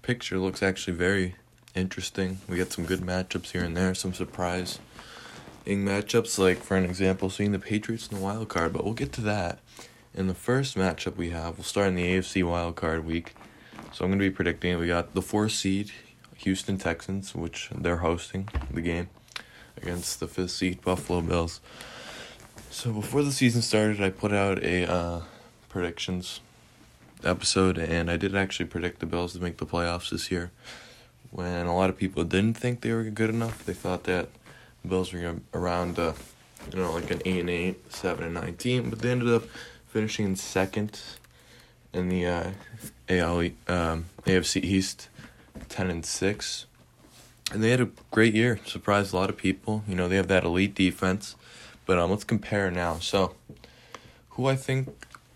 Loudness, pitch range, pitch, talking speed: -28 LUFS, 90-105 Hz, 95 Hz, 180 wpm